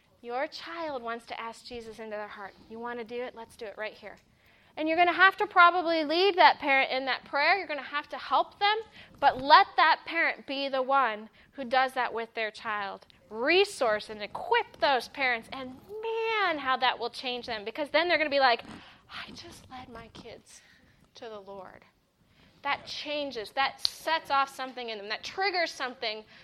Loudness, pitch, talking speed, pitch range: -27 LUFS, 260 Hz, 205 wpm, 230-320 Hz